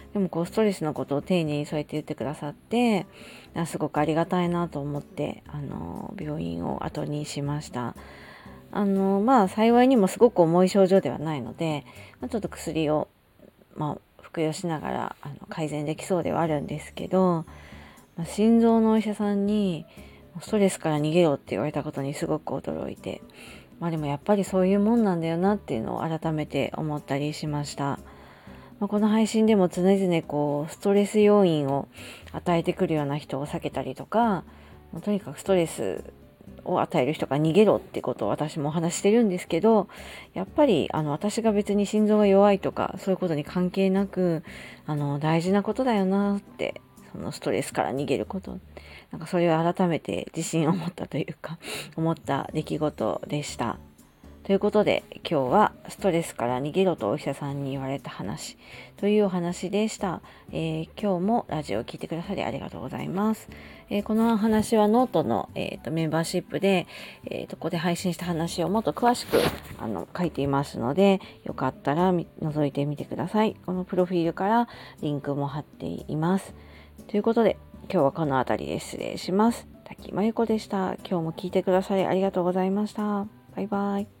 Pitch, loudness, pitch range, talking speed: 170 Hz, -26 LUFS, 145-200 Hz, 365 characters per minute